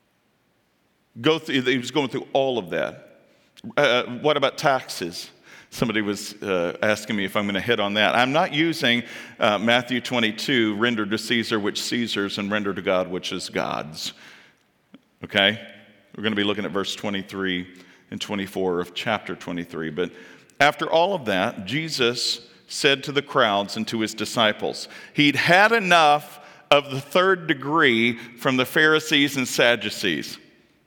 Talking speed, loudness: 160 wpm, -22 LUFS